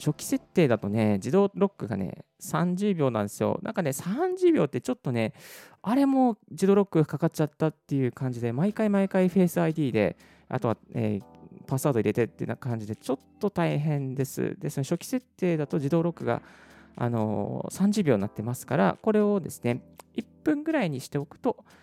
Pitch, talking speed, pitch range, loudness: 155 Hz, 375 characters per minute, 120-195 Hz, -27 LUFS